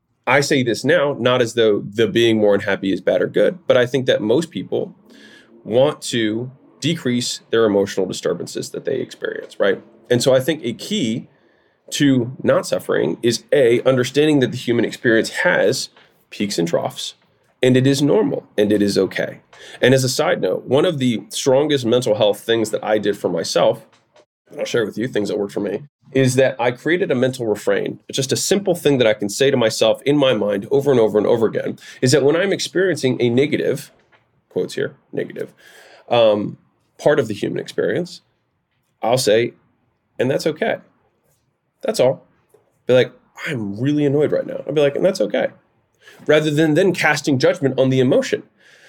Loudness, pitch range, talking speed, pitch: -18 LUFS, 115-145 Hz, 195 wpm, 130 Hz